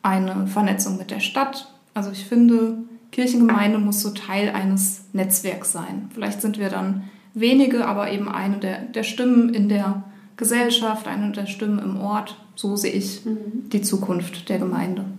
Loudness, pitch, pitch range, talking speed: -22 LUFS, 205 Hz, 195-225 Hz, 160 wpm